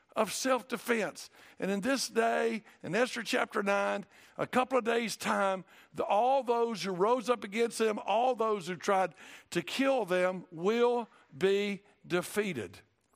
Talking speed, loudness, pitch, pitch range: 155 wpm, -31 LUFS, 220 Hz, 195-240 Hz